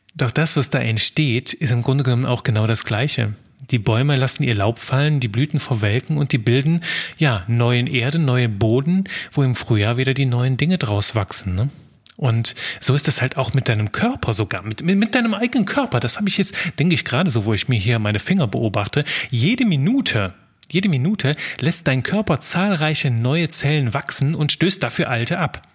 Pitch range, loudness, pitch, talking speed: 120-160 Hz, -19 LUFS, 135 Hz, 200 wpm